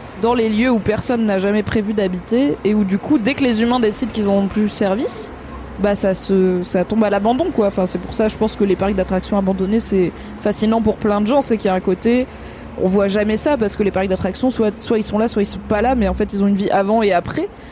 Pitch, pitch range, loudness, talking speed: 210 Hz, 195-225 Hz, -17 LUFS, 290 wpm